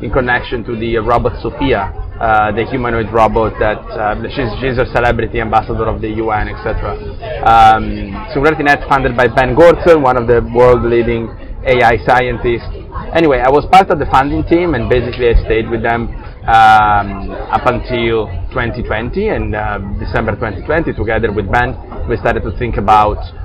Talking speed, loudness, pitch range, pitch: 165 wpm, -13 LUFS, 105-120 Hz, 115 Hz